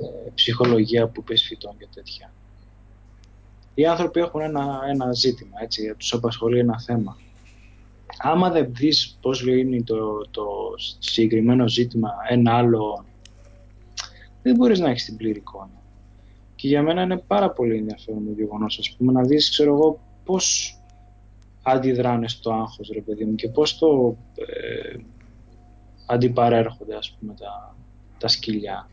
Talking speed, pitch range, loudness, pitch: 135 wpm, 105-125 Hz, -21 LUFS, 115 Hz